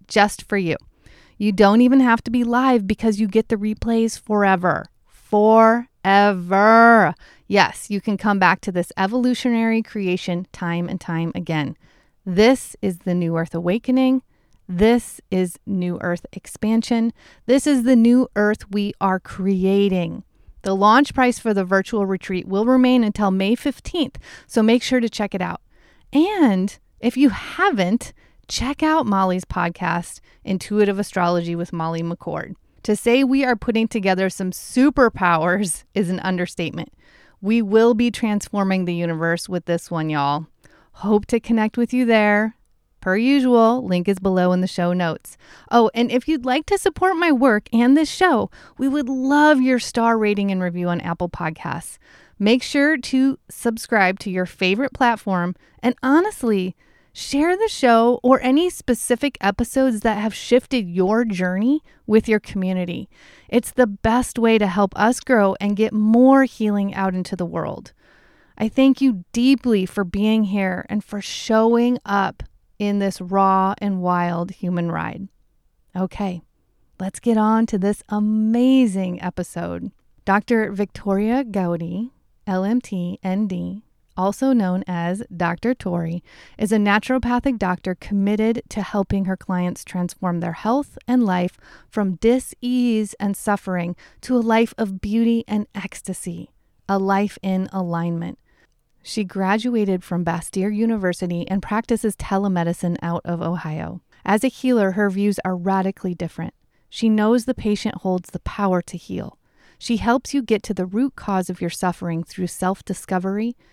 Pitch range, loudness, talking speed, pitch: 185-235 Hz, -20 LUFS, 150 wpm, 205 Hz